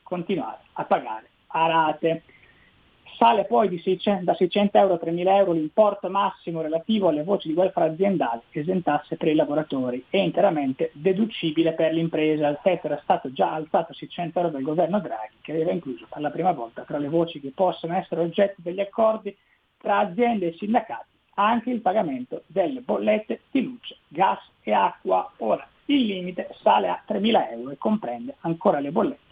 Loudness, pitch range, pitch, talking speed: -24 LUFS, 155-200 Hz, 170 Hz, 180 wpm